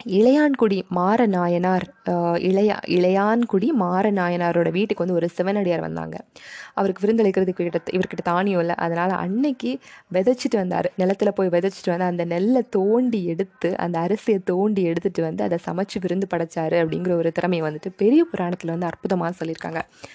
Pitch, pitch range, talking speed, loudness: 185 Hz, 175-205 Hz, 135 wpm, -22 LUFS